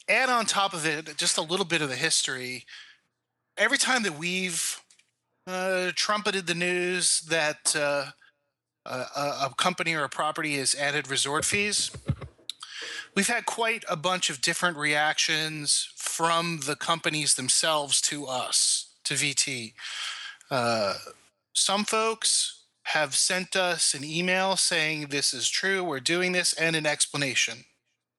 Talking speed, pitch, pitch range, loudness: 140 wpm, 165 Hz, 150-185 Hz, -25 LUFS